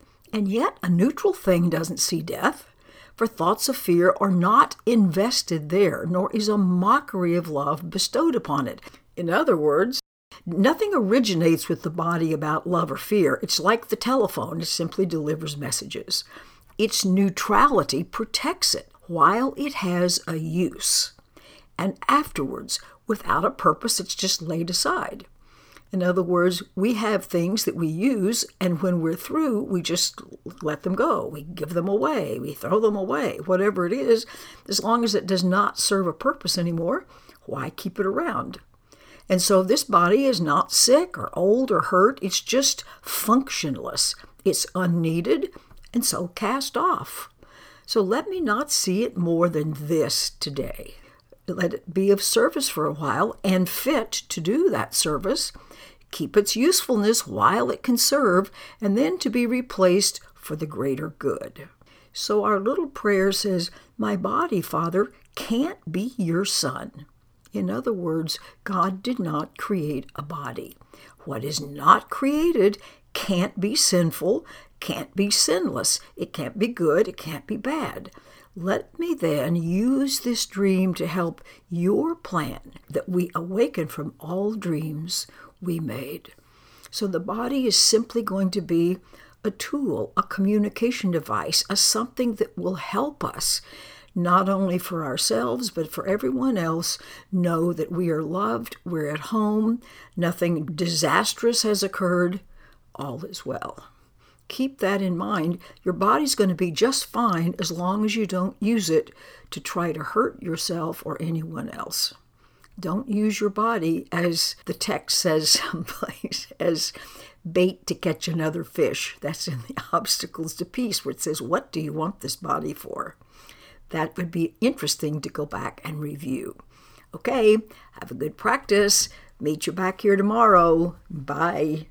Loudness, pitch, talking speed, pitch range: -23 LUFS, 190 Hz, 155 wpm, 170-220 Hz